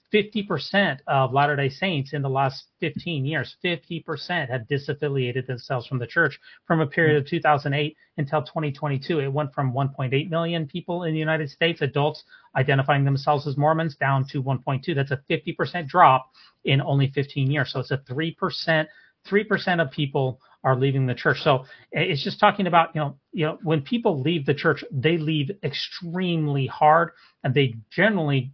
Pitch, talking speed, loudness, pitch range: 150 Hz, 170 wpm, -24 LUFS, 135-165 Hz